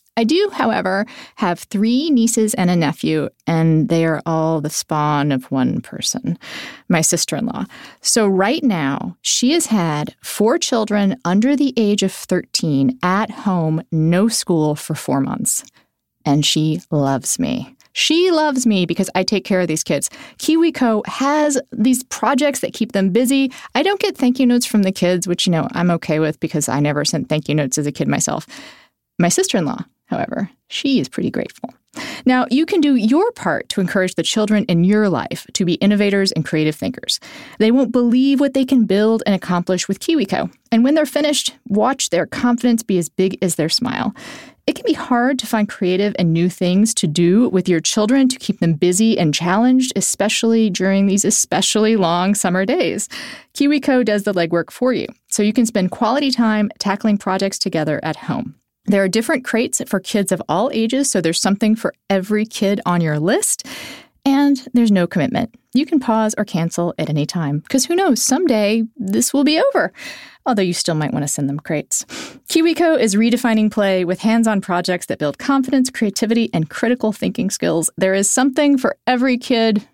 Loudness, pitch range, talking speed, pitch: -17 LUFS, 175-250 Hz, 190 wpm, 210 Hz